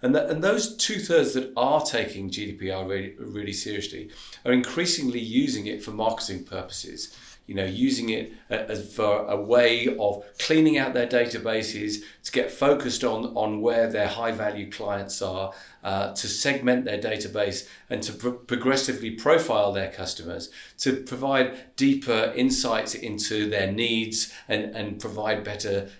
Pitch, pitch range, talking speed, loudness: 110 Hz, 100-130 Hz, 155 wpm, -26 LUFS